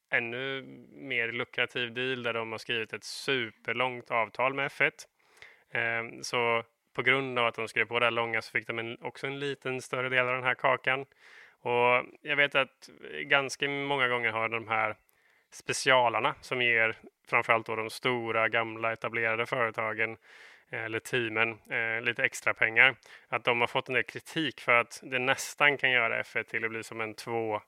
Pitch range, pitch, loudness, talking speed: 115-130 Hz, 120 Hz, -29 LUFS, 175 wpm